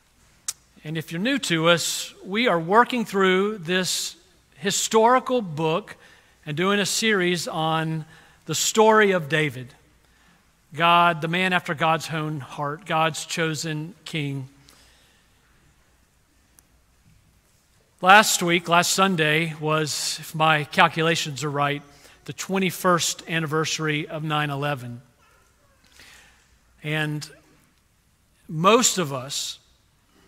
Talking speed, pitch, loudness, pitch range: 105 wpm, 160 Hz, -22 LUFS, 150-185 Hz